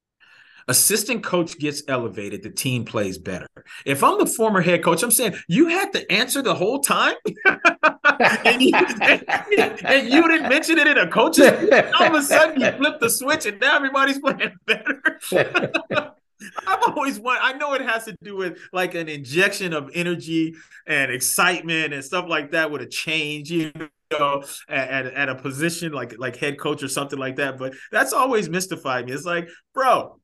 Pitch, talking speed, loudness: 180 Hz, 185 wpm, -19 LUFS